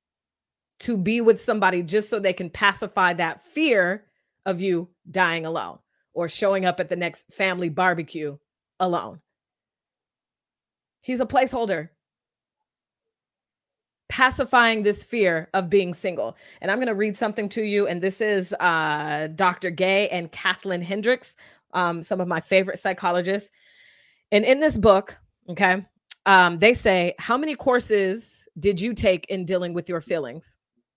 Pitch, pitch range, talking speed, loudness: 190 Hz, 175-215 Hz, 145 wpm, -22 LUFS